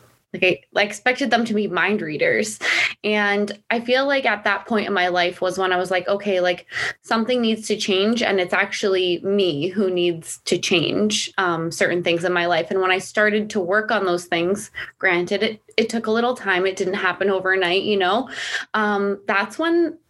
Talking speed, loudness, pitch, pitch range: 200 wpm, -20 LUFS, 200 Hz, 185-215 Hz